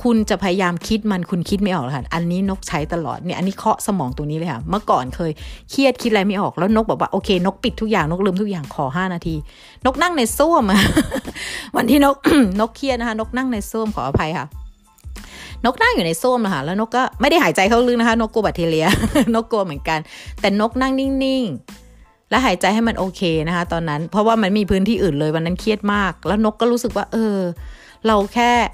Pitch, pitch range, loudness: 205 Hz, 175-235 Hz, -18 LUFS